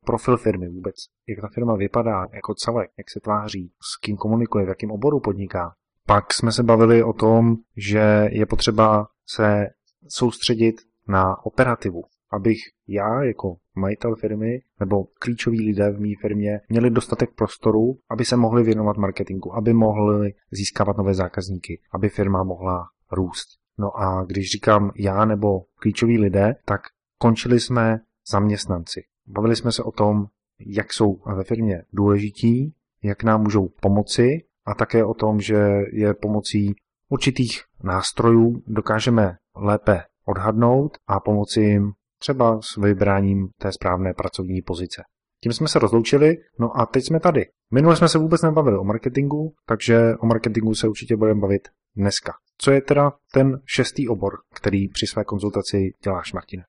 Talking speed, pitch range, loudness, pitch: 150 wpm, 100-115 Hz, -21 LUFS, 110 Hz